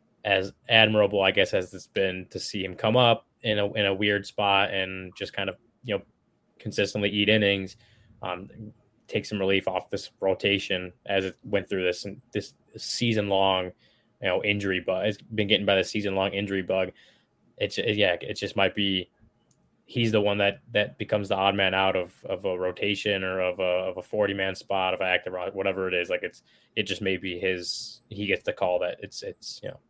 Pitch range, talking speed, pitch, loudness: 95-105 Hz, 215 wpm, 100 Hz, -26 LUFS